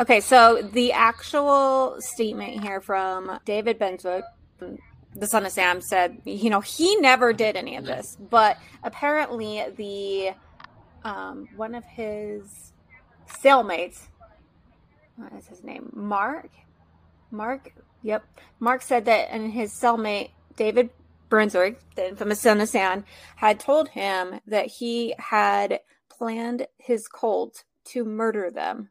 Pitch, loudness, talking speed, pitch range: 220 Hz, -23 LUFS, 130 wpm, 205-245 Hz